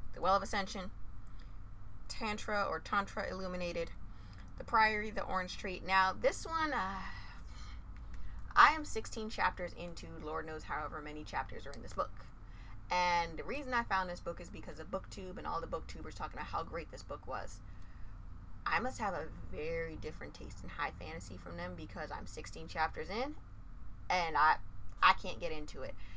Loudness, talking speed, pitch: -37 LUFS, 175 wpm, 175 Hz